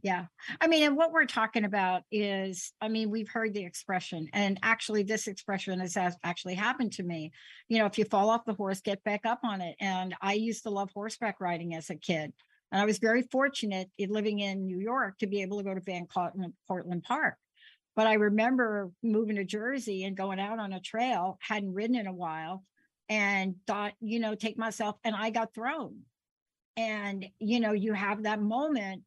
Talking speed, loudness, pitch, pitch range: 210 wpm, -31 LUFS, 210 Hz, 190-225 Hz